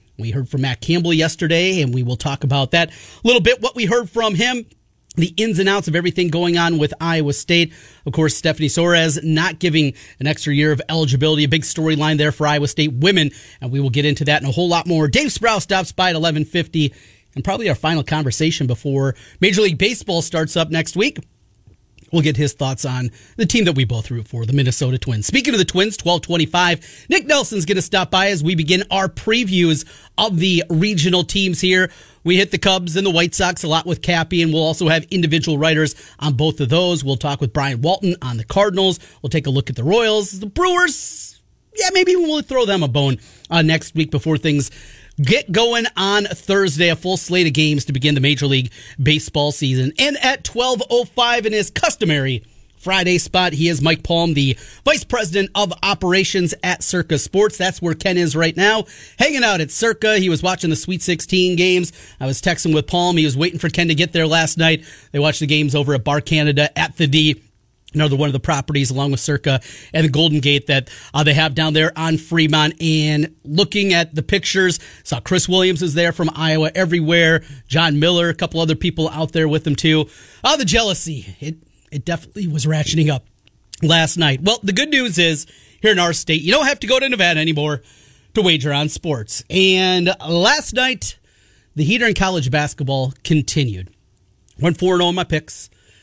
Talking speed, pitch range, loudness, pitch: 210 wpm, 145-185 Hz, -17 LUFS, 160 Hz